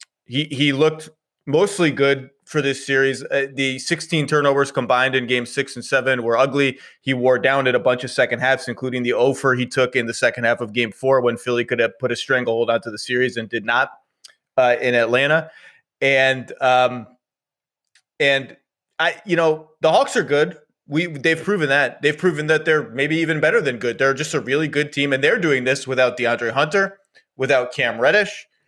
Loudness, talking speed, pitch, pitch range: -19 LUFS, 200 wpm, 135 Hz, 125-150 Hz